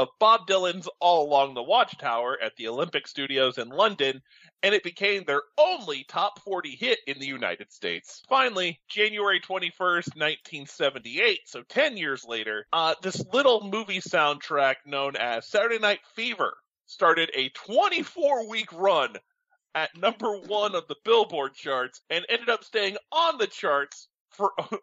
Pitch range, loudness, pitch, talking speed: 145-235 Hz, -26 LUFS, 195 Hz, 150 wpm